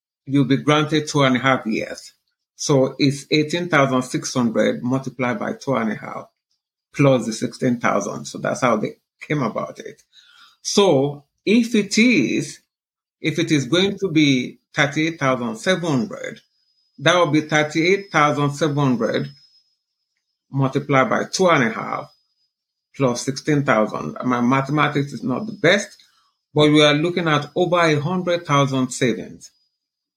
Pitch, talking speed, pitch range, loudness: 145 Hz, 130 wpm, 130-160 Hz, -19 LUFS